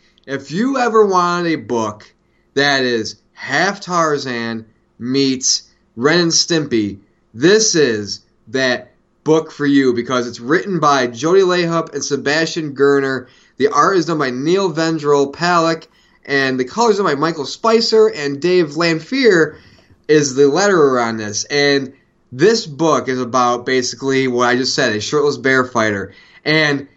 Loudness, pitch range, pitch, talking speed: -15 LUFS, 125-165 Hz, 140 Hz, 150 wpm